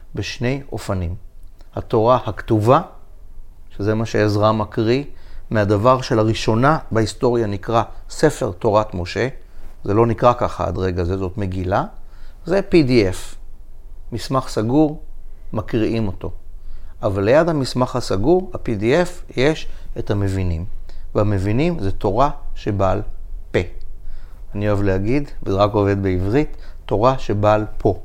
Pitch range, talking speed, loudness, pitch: 90-115 Hz, 115 wpm, -19 LUFS, 105 Hz